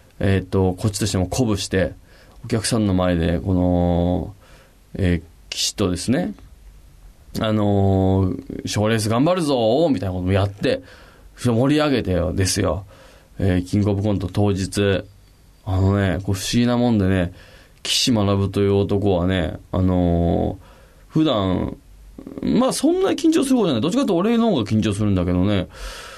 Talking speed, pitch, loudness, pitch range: 315 characters per minute, 100 Hz, -20 LUFS, 90-110 Hz